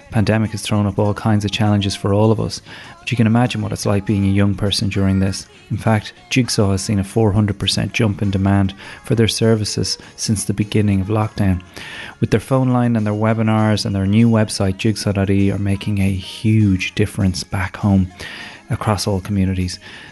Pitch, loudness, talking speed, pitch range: 105 Hz, -18 LUFS, 195 wpm, 95-110 Hz